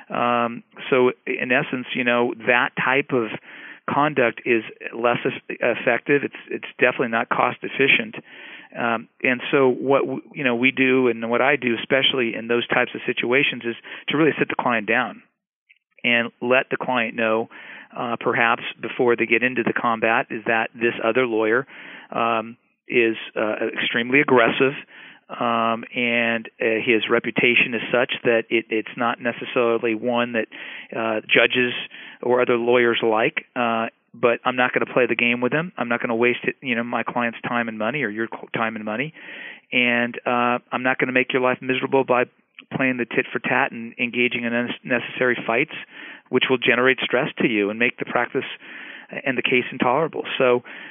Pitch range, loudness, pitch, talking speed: 115-125 Hz, -21 LUFS, 120 Hz, 180 wpm